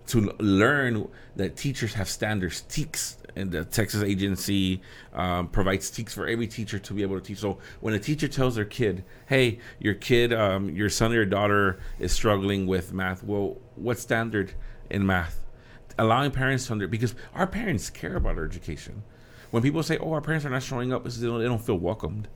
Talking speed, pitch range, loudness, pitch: 200 wpm, 95-120 Hz, -27 LUFS, 105 Hz